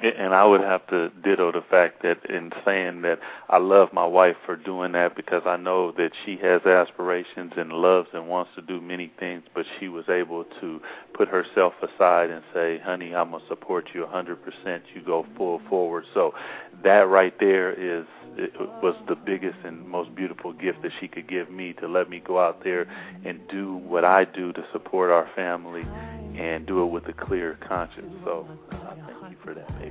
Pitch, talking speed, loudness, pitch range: 90 Hz, 205 wpm, -24 LUFS, 85-90 Hz